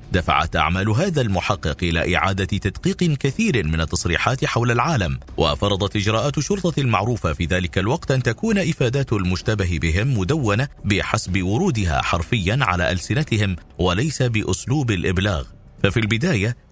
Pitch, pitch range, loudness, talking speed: 105 Hz, 90-130 Hz, -20 LUFS, 125 wpm